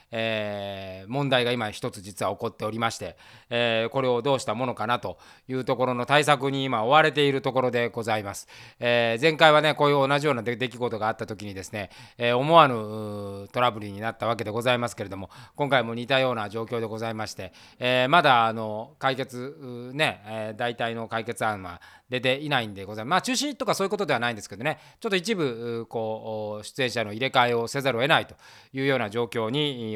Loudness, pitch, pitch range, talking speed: -25 LUFS, 120 Hz, 110-135 Hz, 435 characters per minute